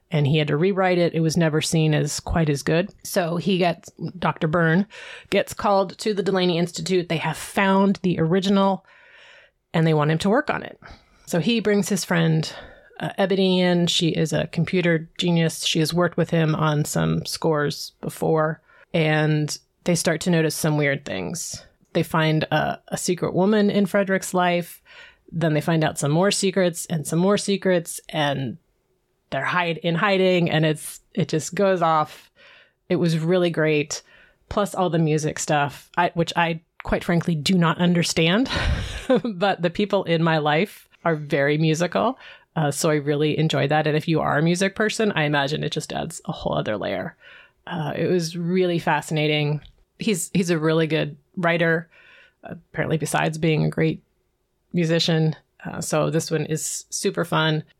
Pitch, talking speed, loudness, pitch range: 170 Hz, 180 wpm, -22 LUFS, 155-185 Hz